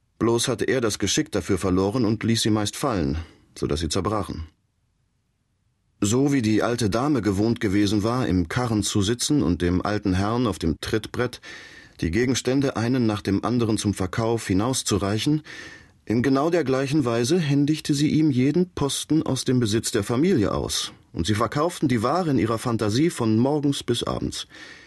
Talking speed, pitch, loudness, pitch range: 170 wpm, 115 Hz, -23 LUFS, 105-130 Hz